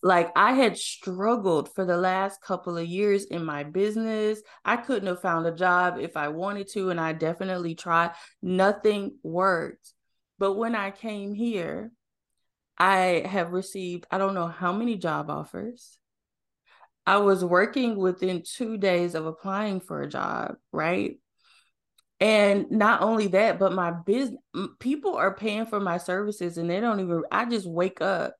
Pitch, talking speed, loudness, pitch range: 195 Hz, 165 wpm, -26 LUFS, 175-215 Hz